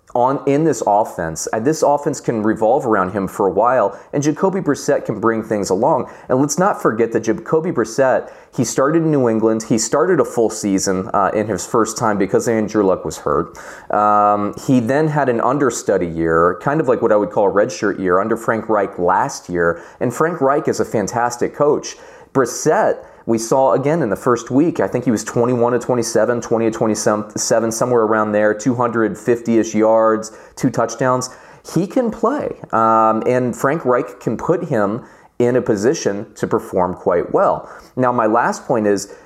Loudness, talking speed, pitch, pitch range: -17 LUFS, 190 wpm, 115 Hz, 110-135 Hz